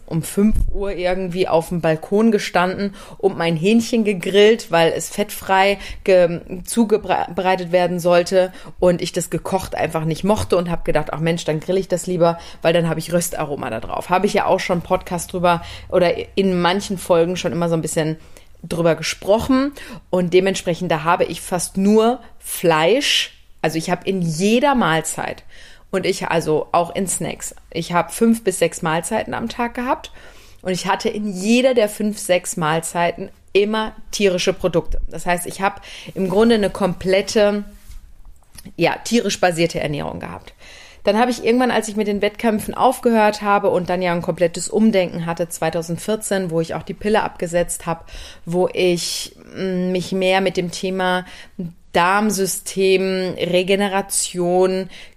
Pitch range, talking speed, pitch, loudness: 175-205 Hz, 165 wpm, 185 Hz, -19 LUFS